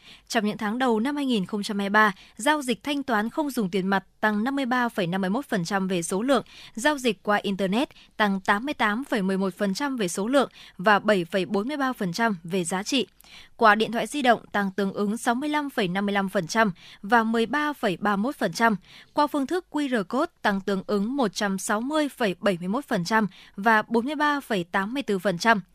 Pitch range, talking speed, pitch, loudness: 200-255 Hz, 130 wpm, 215 Hz, -25 LUFS